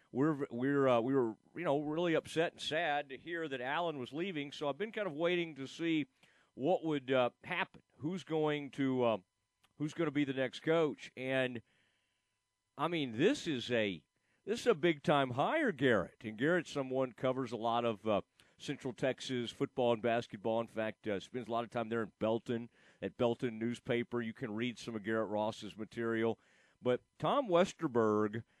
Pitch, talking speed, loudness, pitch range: 130 Hz, 190 wpm, -36 LUFS, 115-150 Hz